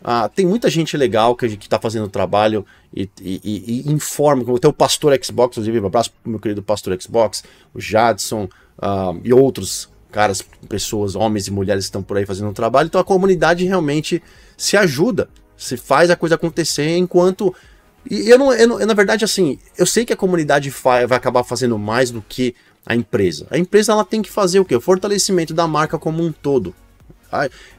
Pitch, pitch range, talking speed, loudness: 125 Hz, 105-175 Hz, 200 wpm, -17 LUFS